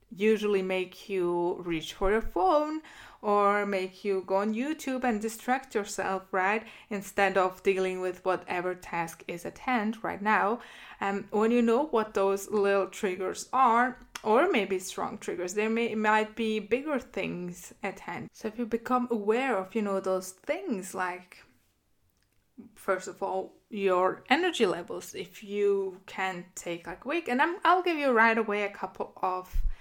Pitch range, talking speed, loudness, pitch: 190-230 Hz, 170 wpm, -29 LUFS, 205 Hz